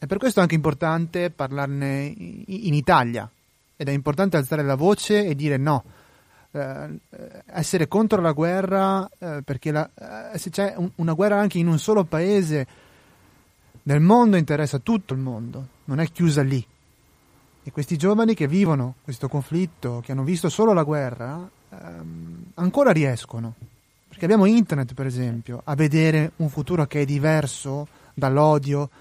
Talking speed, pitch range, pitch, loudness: 155 wpm, 135-180 Hz, 155 Hz, -22 LUFS